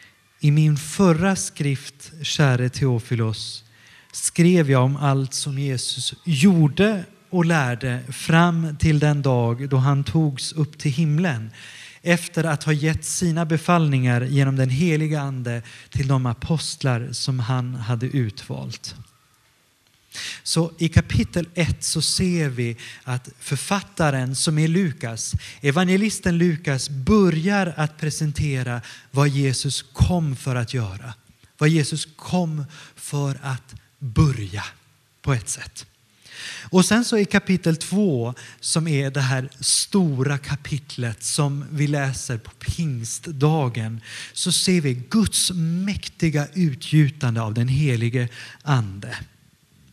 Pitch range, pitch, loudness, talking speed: 125-160 Hz, 140 Hz, -22 LUFS, 120 wpm